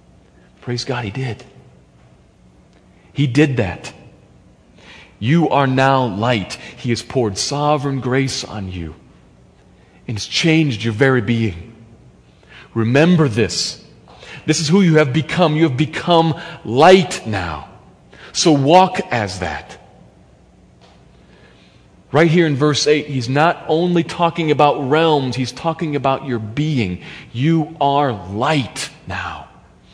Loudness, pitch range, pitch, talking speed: -17 LUFS, 115-155 Hz, 135 Hz, 120 wpm